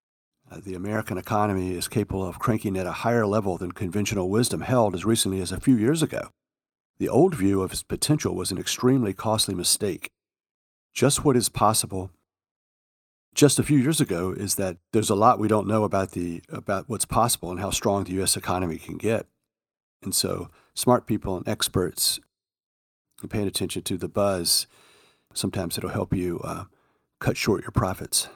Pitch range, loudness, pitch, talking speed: 95-115 Hz, -24 LUFS, 100 Hz, 180 wpm